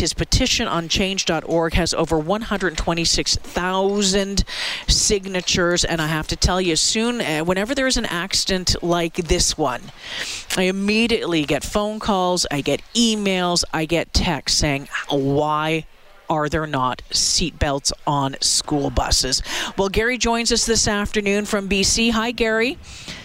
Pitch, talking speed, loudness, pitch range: 180 Hz, 135 wpm, -19 LUFS, 155-210 Hz